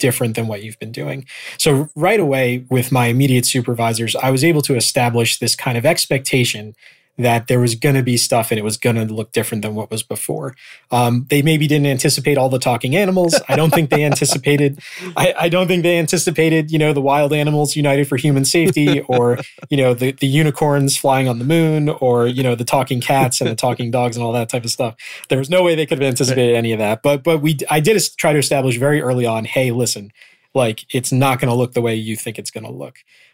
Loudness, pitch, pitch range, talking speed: -16 LUFS, 135 Hz, 120-150 Hz, 240 wpm